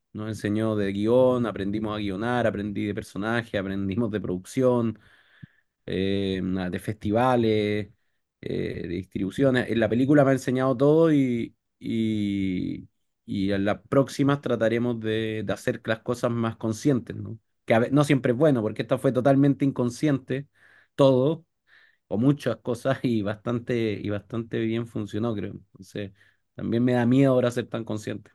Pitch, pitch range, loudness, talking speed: 115 Hz, 105-125 Hz, -25 LUFS, 155 wpm